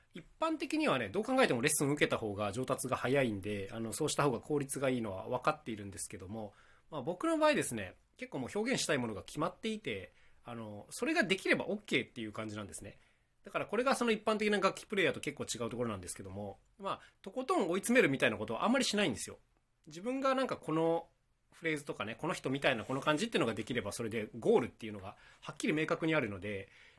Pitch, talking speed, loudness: 140 Hz, 505 characters per minute, -34 LUFS